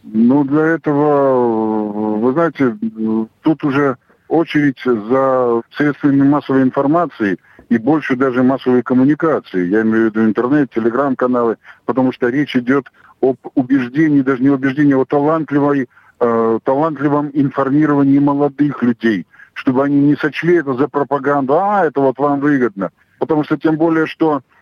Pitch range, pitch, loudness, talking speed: 125-150 Hz, 140 Hz, -15 LUFS, 135 wpm